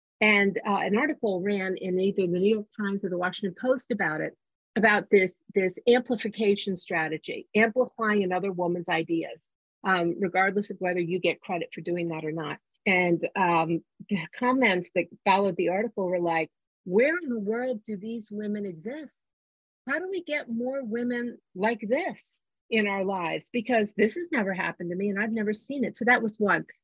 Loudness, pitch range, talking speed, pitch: -27 LUFS, 185-230 Hz, 185 wpm, 205 Hz